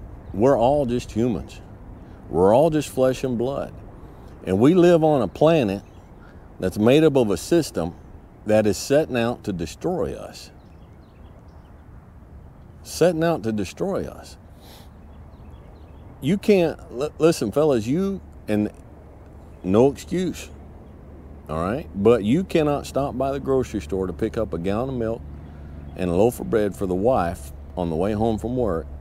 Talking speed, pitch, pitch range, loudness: 155 wpm, 100 Hz, 80-125 Hz, -22 LUFS